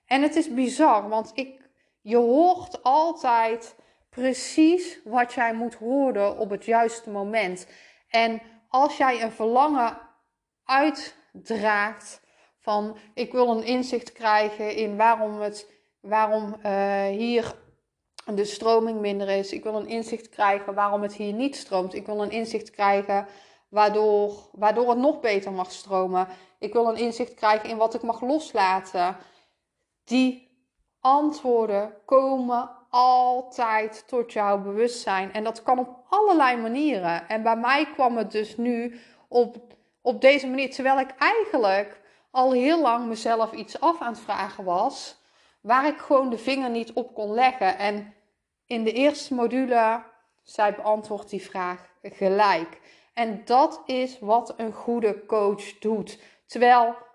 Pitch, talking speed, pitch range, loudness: 230 Hz, 145 wpm, 210-255 Hz, -24 LUFS